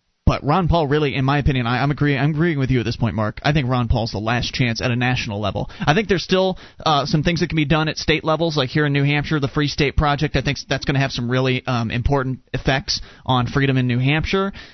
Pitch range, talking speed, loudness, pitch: 125-155 Hz, 275 wpm, -20 LUFS, 140 Hz